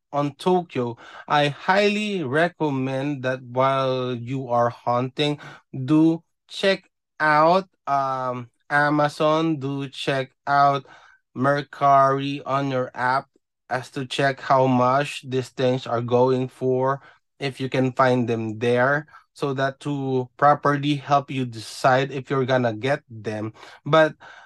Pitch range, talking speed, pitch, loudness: 130-145 Hz, 125 wpm, 135 Hz, -22 LUFS